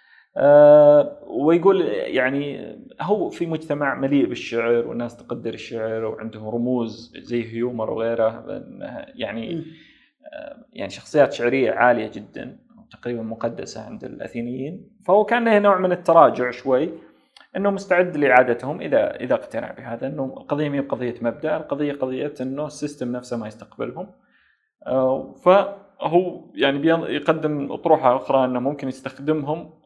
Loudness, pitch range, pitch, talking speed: -21 LUFS, 120-180 Hz, 140 Hz, 115 wpm